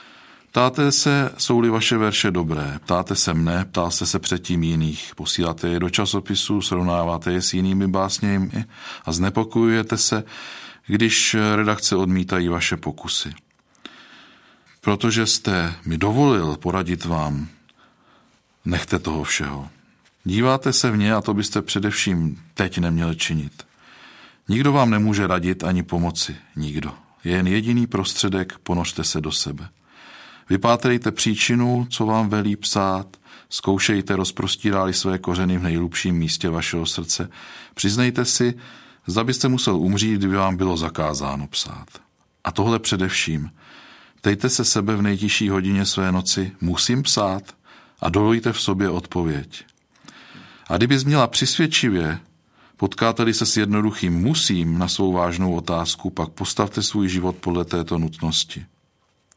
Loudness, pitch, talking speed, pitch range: -20 LUFS, 95 Hz, 130 wpm, 85-110 Hz